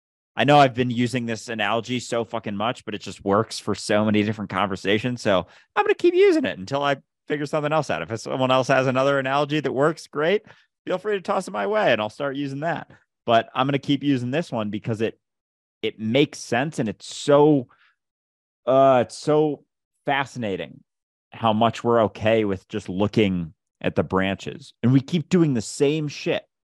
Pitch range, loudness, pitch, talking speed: 105-145 Hz, -22 LUFS, 125 Hz, 200 wpm